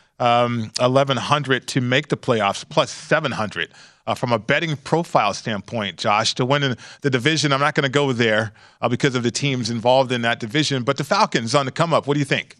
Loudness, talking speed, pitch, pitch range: -20 LUFS, 220 wpm, 135 Hz, 120-145 Hz